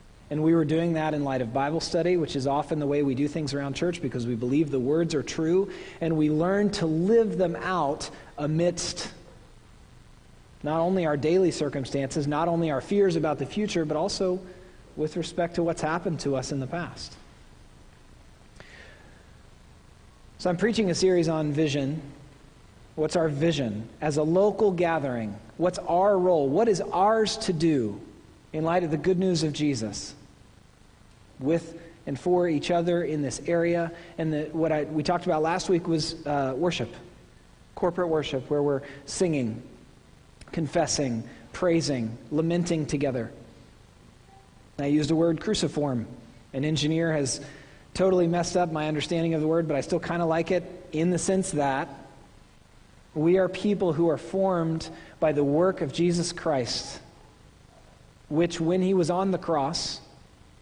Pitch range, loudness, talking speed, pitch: 140-175 Hz, -26 LUFS, 165 wpm, 160 Hz